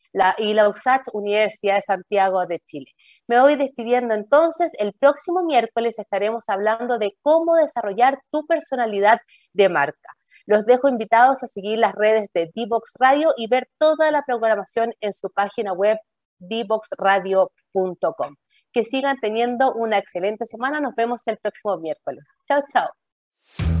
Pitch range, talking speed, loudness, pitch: 200-260 Hz, 145 wpm, -20 LUFS, 225 Hz